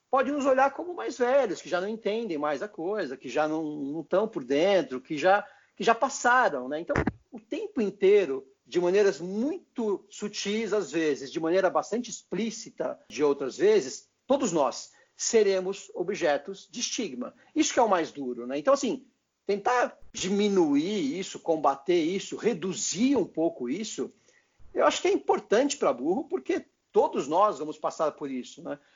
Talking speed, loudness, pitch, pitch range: 170 wpm, -27 LUFS, 215 Hz, 180-280 Hz